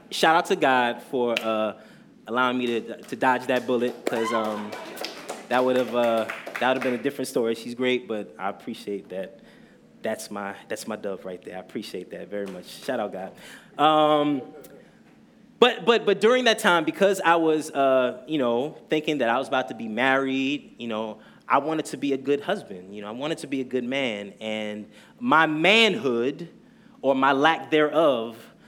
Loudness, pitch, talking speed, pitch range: -24 LUFS, 130 Hz, 190 wpm, 115-155 Hz